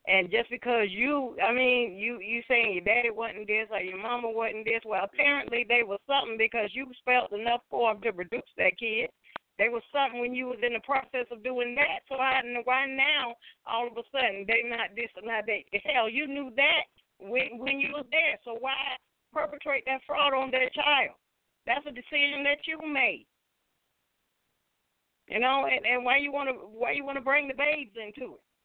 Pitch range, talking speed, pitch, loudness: 230-275 Hz, 205 wpm, 250 Hz, -28 LUFS